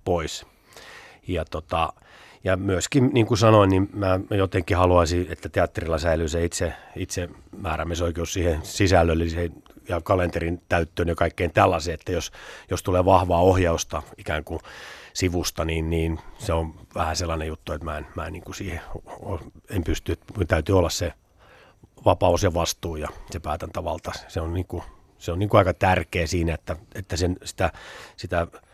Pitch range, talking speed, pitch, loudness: 85-95 Hz, 165 wpm, 90 Hz, -24 LUFS